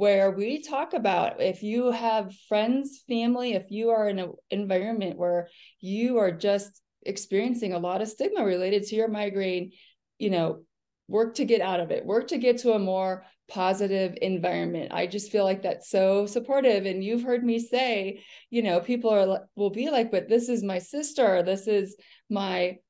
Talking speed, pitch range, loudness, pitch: 185 wpm, 190-230 Hz, -27 LUFS, 205 Hz